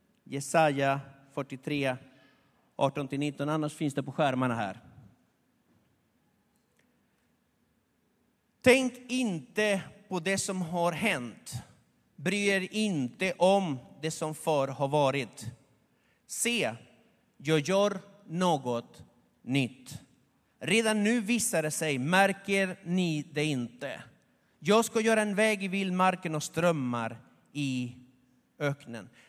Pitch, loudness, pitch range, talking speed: 155 Hz, -29 LUFS, 135-195 Hz, 100 wpm